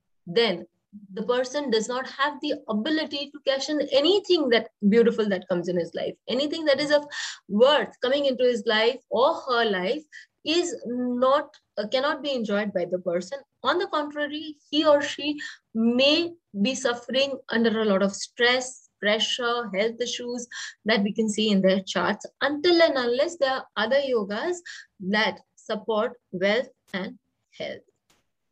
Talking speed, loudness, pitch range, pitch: 160 wpm, -25 LUFS, 215-285 Hz, 245 Hz